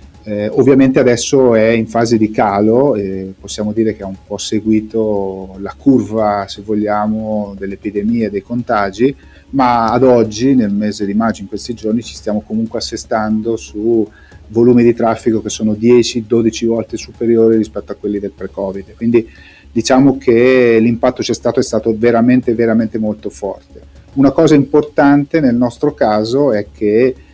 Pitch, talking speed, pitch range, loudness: 110 Hz, 160 wpm, 105-120 Hz, -13 LUFS